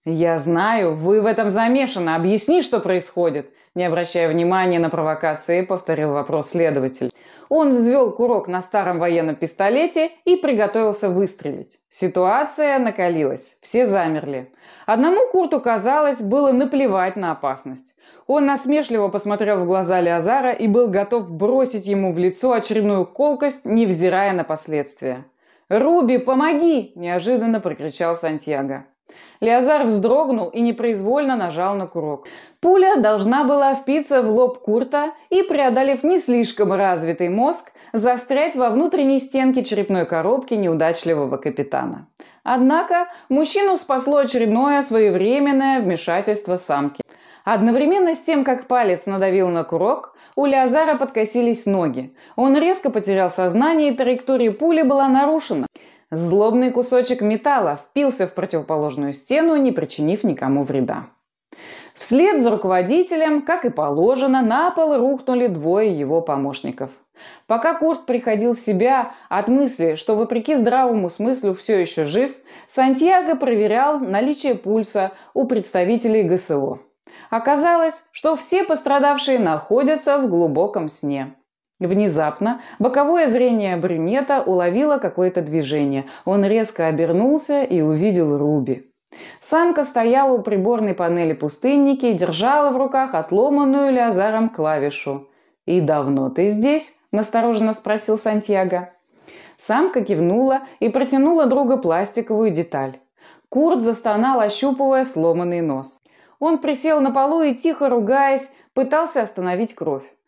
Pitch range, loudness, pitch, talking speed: 180-275 Hz, -19 LUFS, 225 Hz, 120 wpm